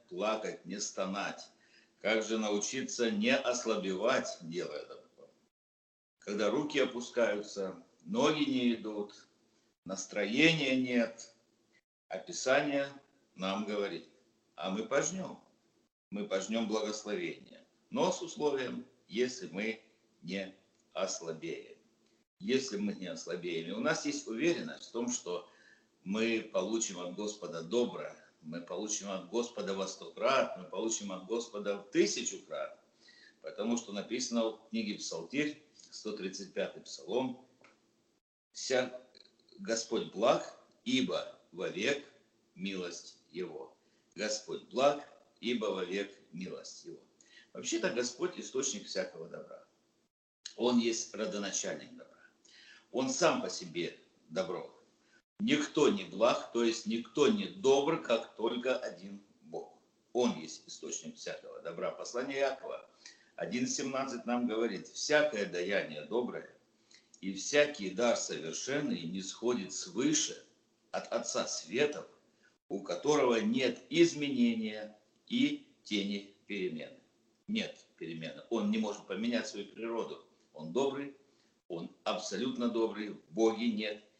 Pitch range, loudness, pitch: 105-140 Hz, -35 LUFS, 115 Hz